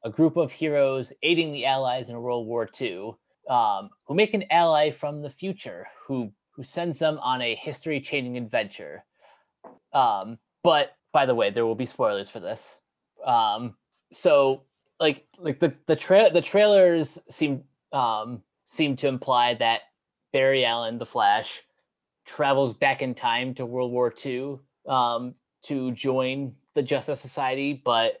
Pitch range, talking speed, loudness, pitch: 125-155 Hz, 155 wpm, -25 LUFS, 135 Hz